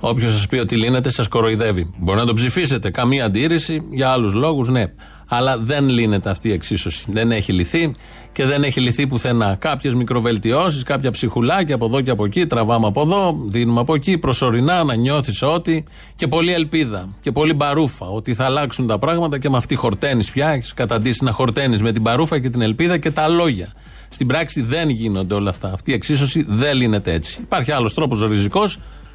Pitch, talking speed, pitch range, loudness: 125 Hz, 195 wpm, 110-145 Hz, -18 LUFS